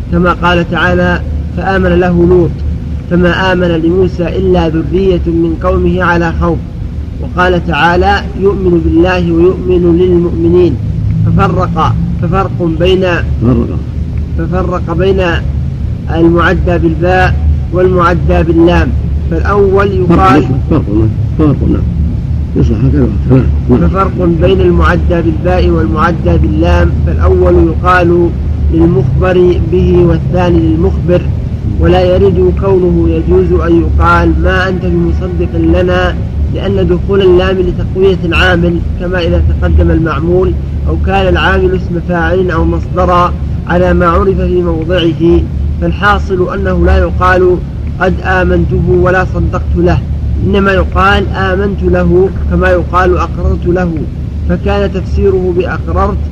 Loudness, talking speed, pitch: -10 LUFS, 100 wpm, 90 Hz